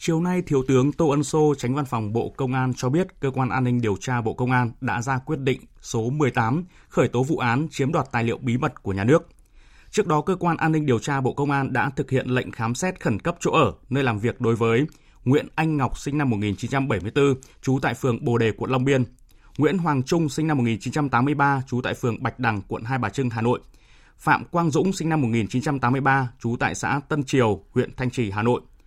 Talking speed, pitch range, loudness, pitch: 240 wpm, 120-150 Hz, -23 LUFS, 130 Hz